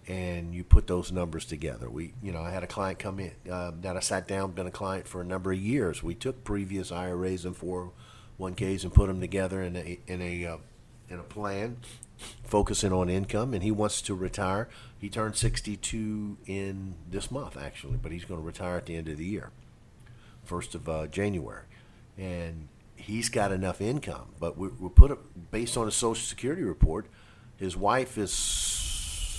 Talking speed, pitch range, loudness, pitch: 200 wpm, 90-110 Hz, -31 LUFS, 95 Hz